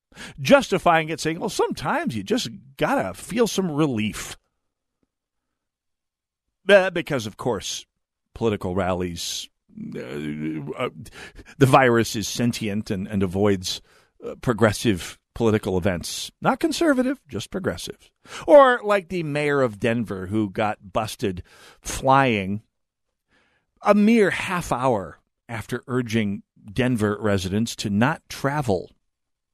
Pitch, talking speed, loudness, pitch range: 115 Hz, 110 wpm, -22 LUFS, 100-160 Hz